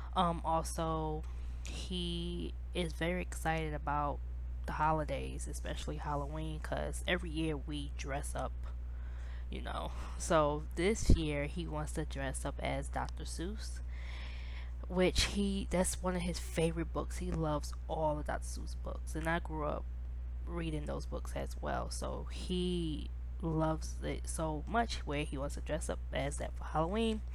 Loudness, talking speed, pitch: -38 LUFS, 155 wpm, 70 Hz